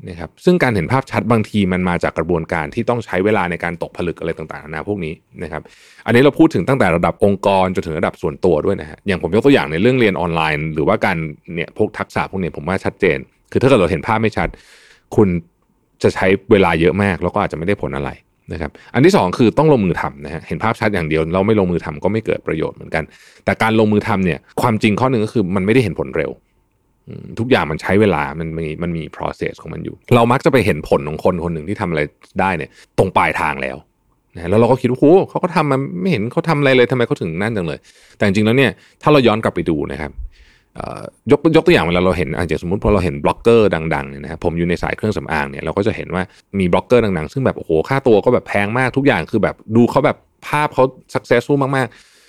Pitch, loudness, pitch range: 100 Hz, -16 LUFS, 80-120 Hz